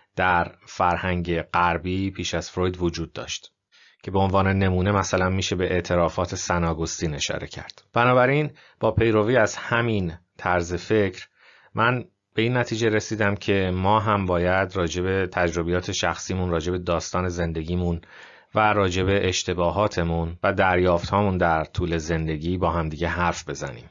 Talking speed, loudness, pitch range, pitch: 135 wpm, -23 LUFS, 85-100 Hz, 90 Hz